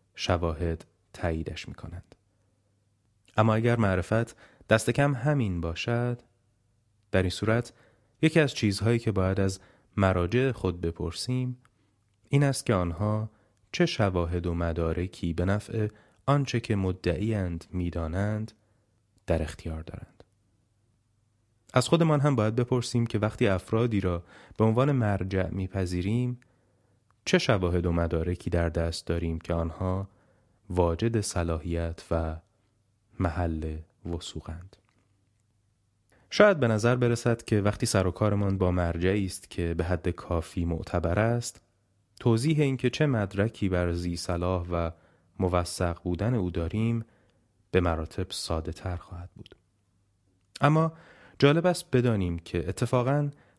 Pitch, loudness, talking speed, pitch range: 100 Hz, -28 LUFS, 120 wpm, 90-115 Hz